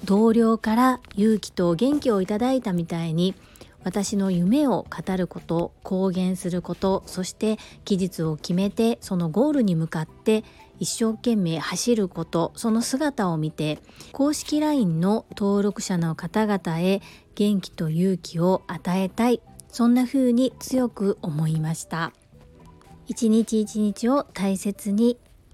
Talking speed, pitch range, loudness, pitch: 260 characters per minute, 180-230 Hz, -24 LUFS, 200 Hz